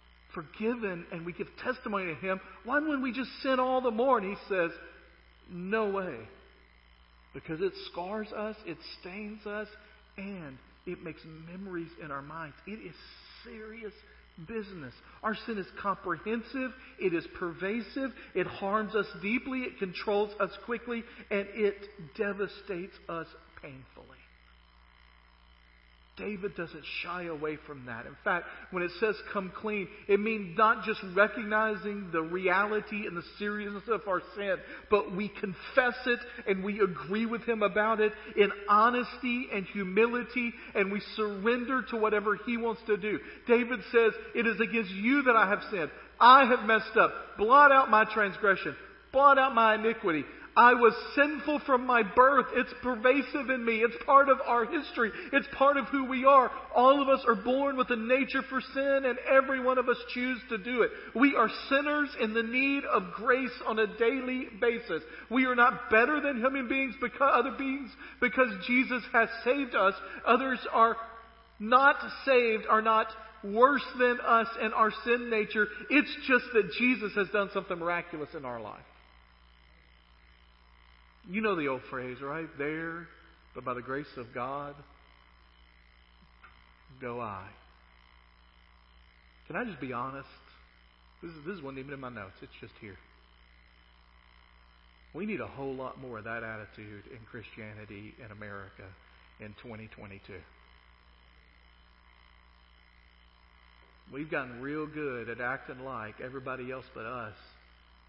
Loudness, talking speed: -29 LUFS, 155 wpm